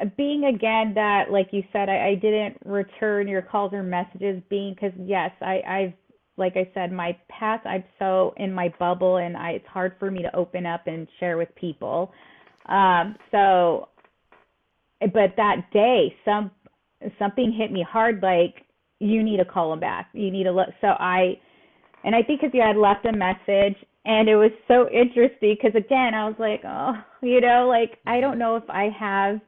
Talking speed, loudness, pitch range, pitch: 190 wpm, -22 LUFS, 185-220 Hz, 200 Hz